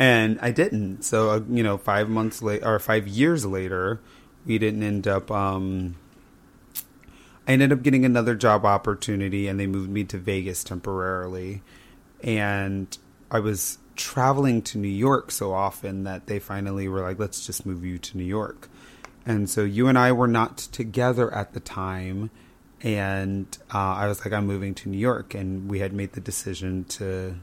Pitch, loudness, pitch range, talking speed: 100 Hz, -25 LUFS, 95-115 Hz, 175 wpm